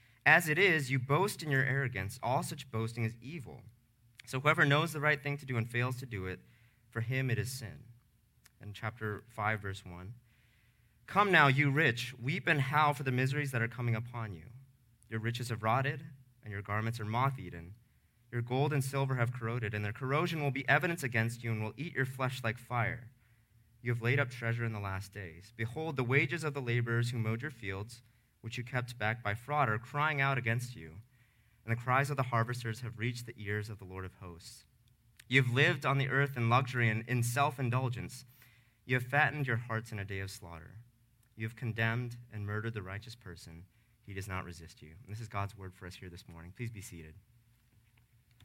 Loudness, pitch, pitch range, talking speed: -33 LUFS, 120 Hz, 110-130 Hz, 210 wpm